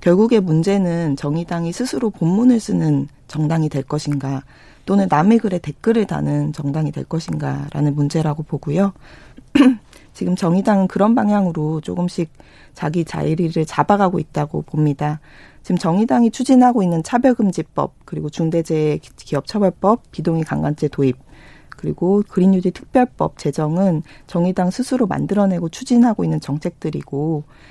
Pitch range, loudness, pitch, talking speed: 150-200 Hz, -18 LUFS, 170 Hz, 335 characters per minute